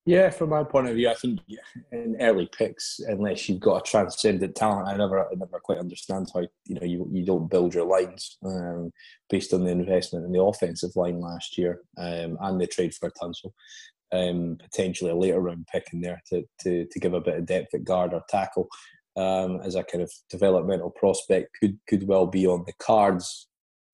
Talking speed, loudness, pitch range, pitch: 215 wpm, -26 LUFS, 90-95 Hz, 90 Hz